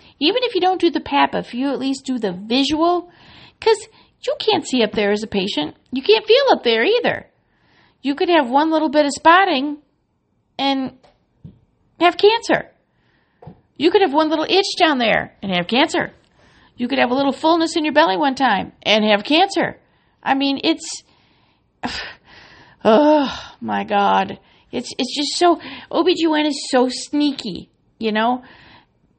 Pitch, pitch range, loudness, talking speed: 290 Hz, 250-335 Hz, -18 LUFS, 165 wpm